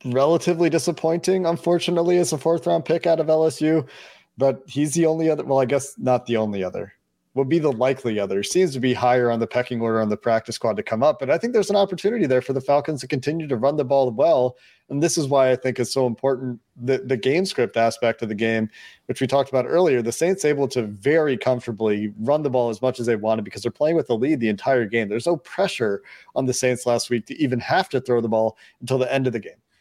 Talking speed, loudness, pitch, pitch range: 250 wpm, -21 LUFS, 130 Hz, 120-155 Hz